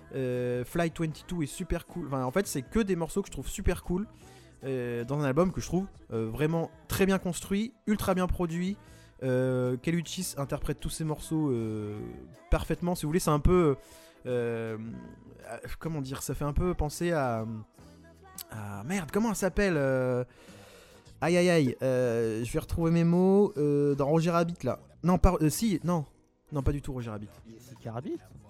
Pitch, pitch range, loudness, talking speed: 145 Hz, 120-175 Hz, -30 LUFS, 185 wpm